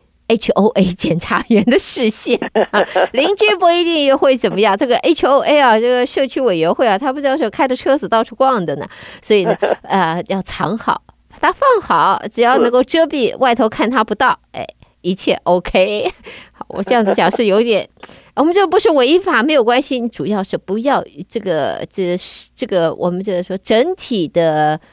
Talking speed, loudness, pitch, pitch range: 275 characters per minute, -14 LUFS, 225 Hz, 185-270 Hz